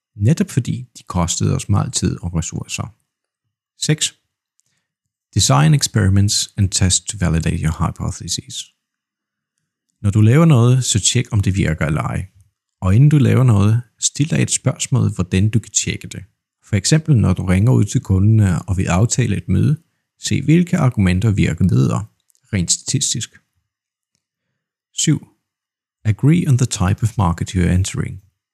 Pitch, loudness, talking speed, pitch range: 110 Hz, -17 LUFS, 150 wpm, 95-130 Hz